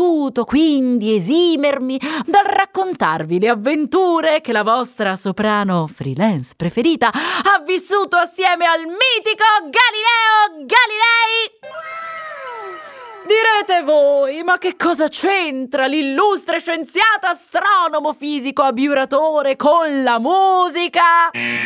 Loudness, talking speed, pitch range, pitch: -15 LUFS, 90 wpm, 275-380 Hz, 330 Hz